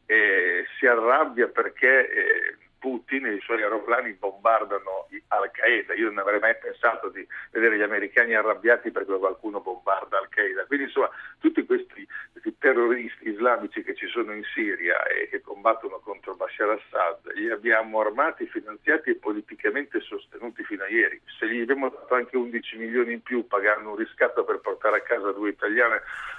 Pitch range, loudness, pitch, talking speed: 315-445 Hz, -24 LUFS, 375 Hz, 175 wpm